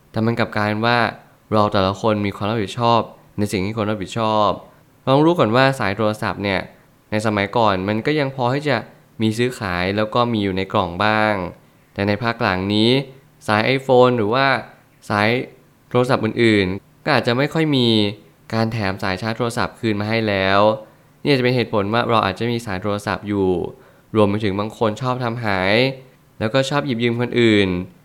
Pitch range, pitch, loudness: 105-125 Hz, 110 Hz, -19 LUFS